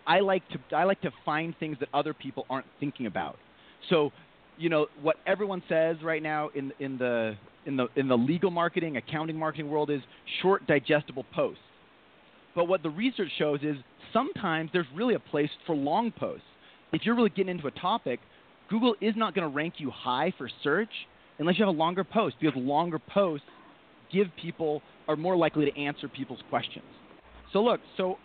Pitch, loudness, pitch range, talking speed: 160 Hz, -29 LUFS, 145-185 Hz, 190 wpm